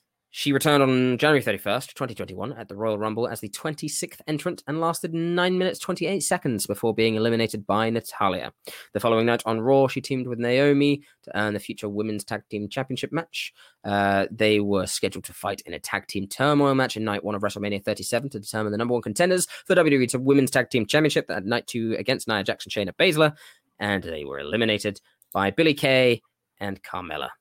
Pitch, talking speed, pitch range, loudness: 120 Hz, 200 wpm, 105-145 Hz, -24 LUFS